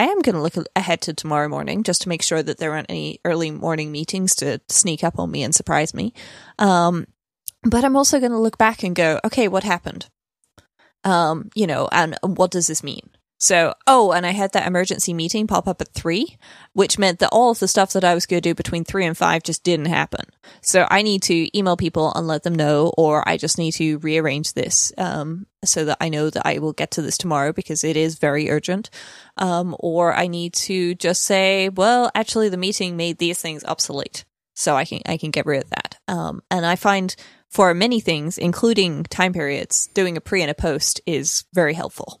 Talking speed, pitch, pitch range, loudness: 225 wpm, 175 Hz, 160-195 Hz, -19 LUFS